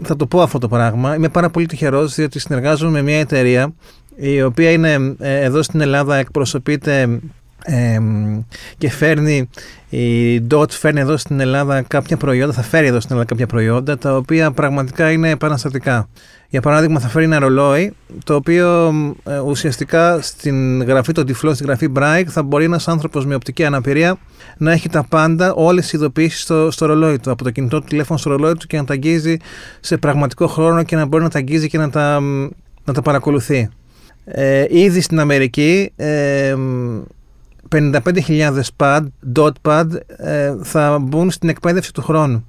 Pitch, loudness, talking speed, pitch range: 150 Hz, -15 LUFS, 175 wpm, 135-160 Hz